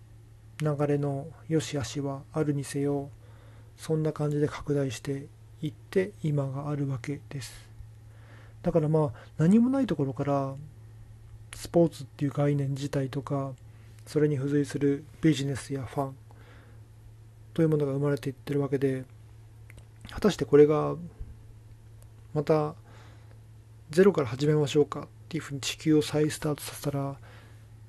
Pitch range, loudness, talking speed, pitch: 110-145 Hz, -28 LUFS, 285 characters per minute, 140 Hz